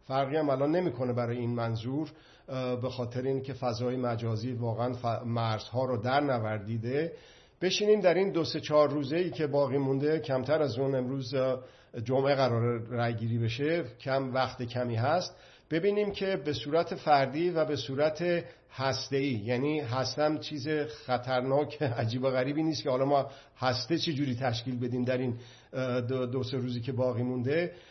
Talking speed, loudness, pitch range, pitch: 160 wpm, -30 LUFS, 125-150 Hz, 130 Hz